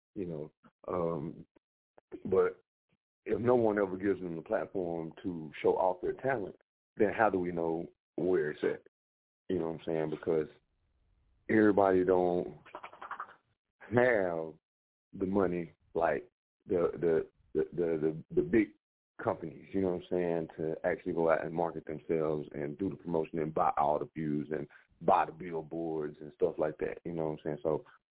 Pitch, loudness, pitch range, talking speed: 80 Hz, -33 LUFS, 75-90 Hz, 170 wpm